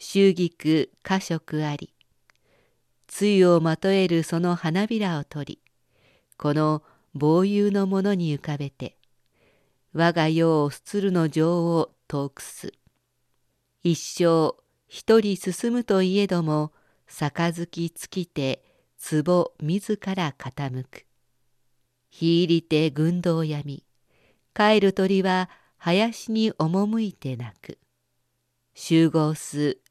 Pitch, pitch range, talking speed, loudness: 165 Hz, 145-190 Hz, 175 characters per minute, -24 LUFS